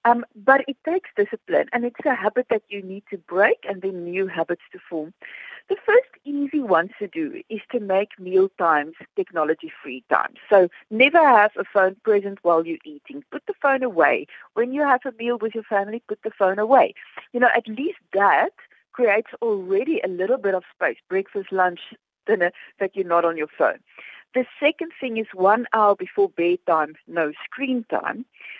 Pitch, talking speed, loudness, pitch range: 215 Hz, 190 wpm, -22 LUFS, 190-275 Hz